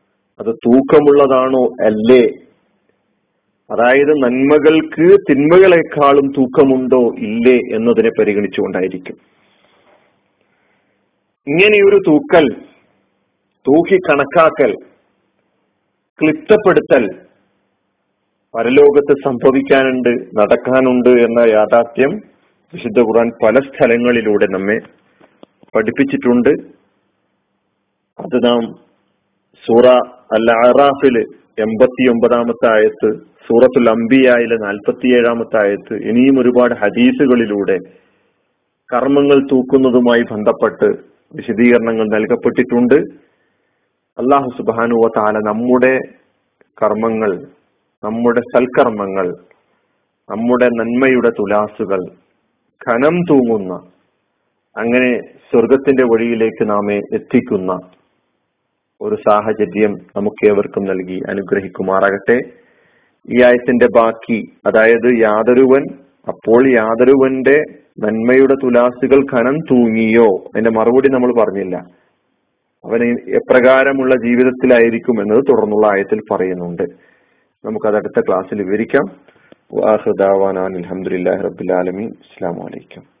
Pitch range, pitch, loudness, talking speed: 110-135 Hz, 120 Hz, -13 LUFS, 70 wpm